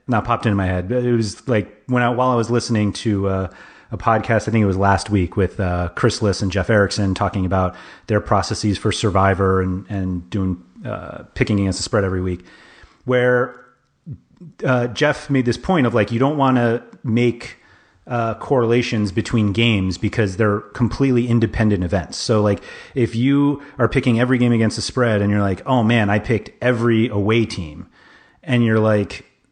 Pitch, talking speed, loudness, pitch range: 110 Hz, 190 wpm, -19 LUFS, 100-120 Hz